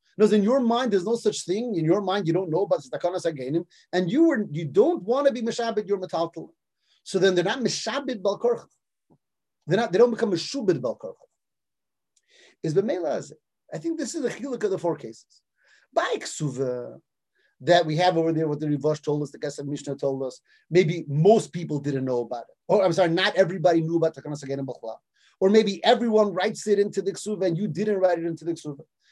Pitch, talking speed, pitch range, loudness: 185 Hz, 210 wpm, 160-220 Hz, -24 LUFS